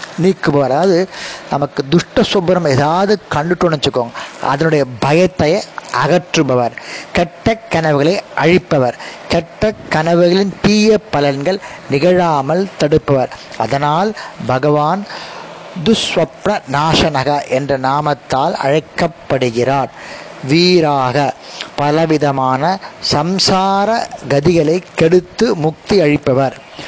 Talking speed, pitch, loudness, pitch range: 60 wpm, 160 Hz, -14 LUFS, 140-185 Hz